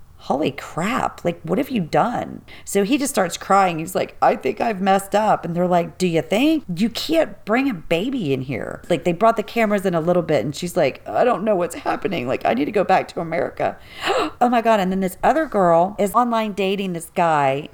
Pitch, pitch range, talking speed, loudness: 195 Hz, 175-225 Hz, 235 wpm, -20 LUFS